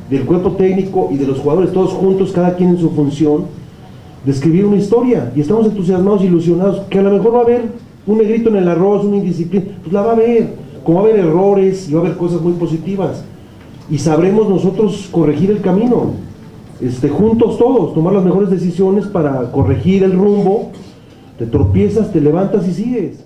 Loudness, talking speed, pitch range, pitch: -13 LUFS, 195 wpm, 160-200 Hz, 185 Hz